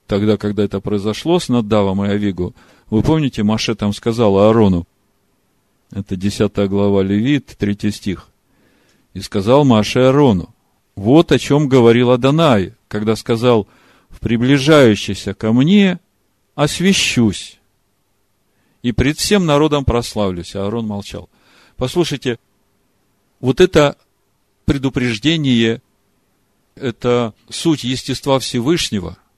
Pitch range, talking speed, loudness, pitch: 100-135 Hz, 105 wpm, -15 LUFS, 110 Hz